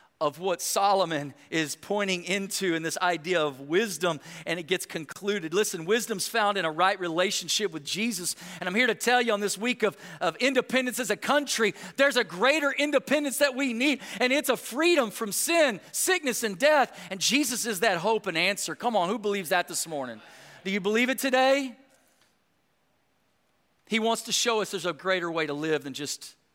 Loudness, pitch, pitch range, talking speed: -26 LUFS, 205 Hz, 175-245 Hz, 195 wpm